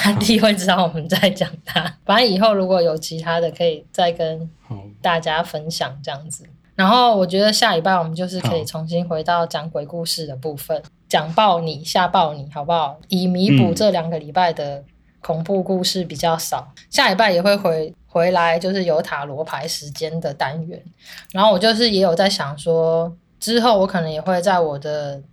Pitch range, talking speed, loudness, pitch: 155-185 Hz, 285 characters per minute, -18 LUFS, 170 Hz